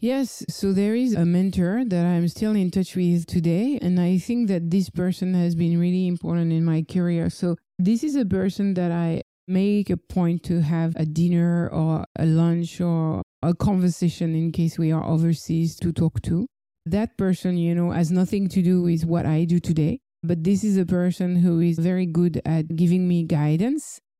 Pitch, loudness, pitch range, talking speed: 175 Hz, -22 LUFS, 165-185 Hz, 200 wpm